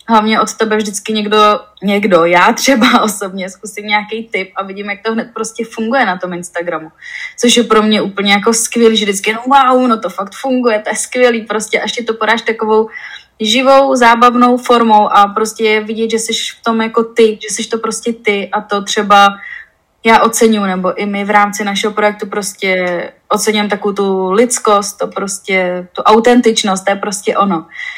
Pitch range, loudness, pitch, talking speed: 200-230 Hz, -12 LUFS, 215 Hz, 190 wpm